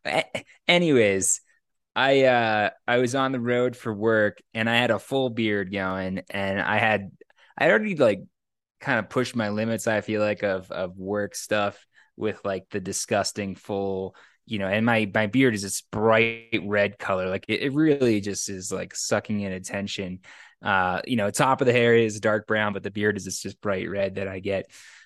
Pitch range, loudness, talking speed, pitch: 100-115 Hz, -24 LUFS, 195 wpm, 105 Hz